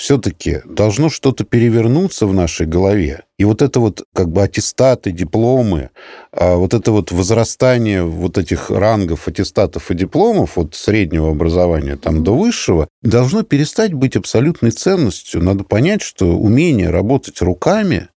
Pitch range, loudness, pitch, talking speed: 90-125 Hz, -15 LUFS, 105 Hz, 140 wpm